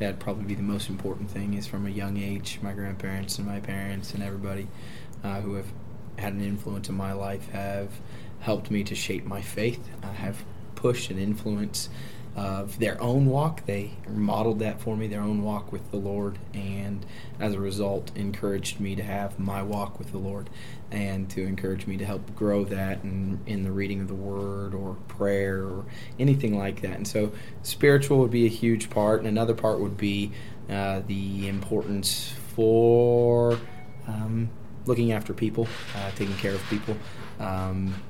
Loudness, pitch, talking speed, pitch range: -28 LUFS, 100 Hz, 185 wpm, 100-110 Hz